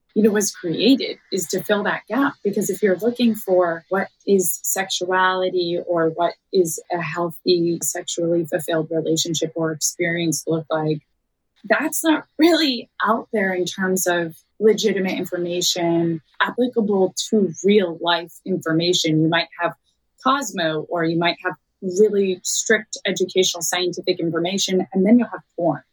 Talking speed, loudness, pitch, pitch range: 145 wpm, -20 LUFS, 180 Hz, 170-205 Hz